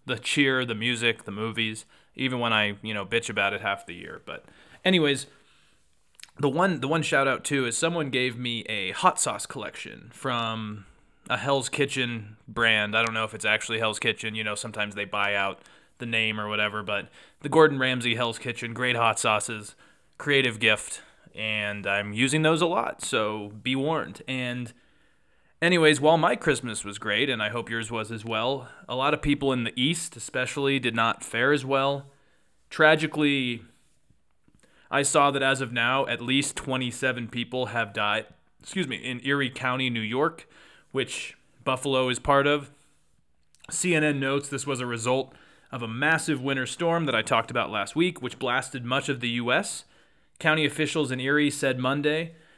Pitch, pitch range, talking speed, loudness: 125 Hz, 115-140 Hz, 180 wpm, -25 LUFS